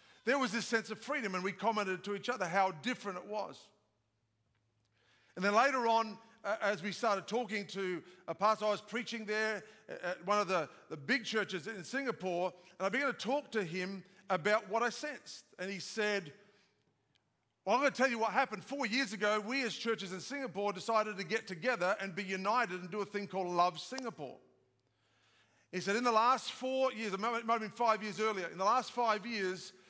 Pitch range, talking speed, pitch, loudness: 185-230 Hz, 205 wpm, 205 Hz, -35 LUFS